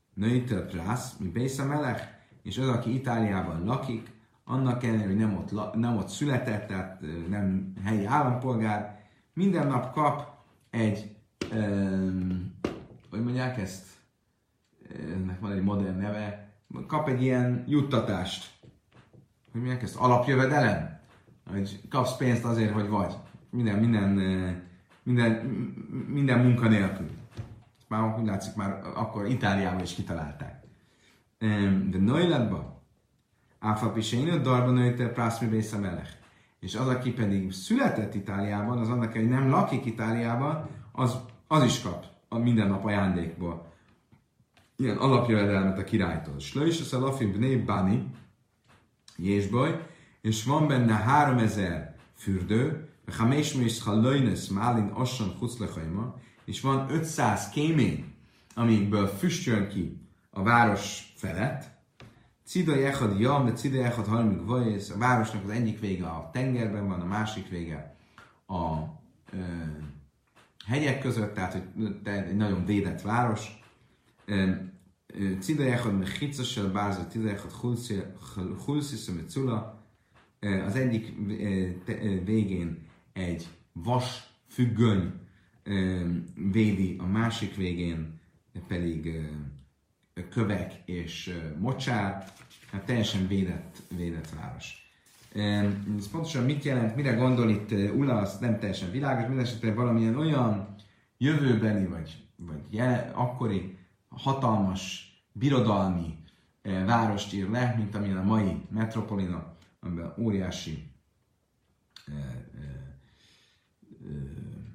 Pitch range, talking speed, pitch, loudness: 95-125 Hz, 105 wpm, 105 Hz, -29 LUFS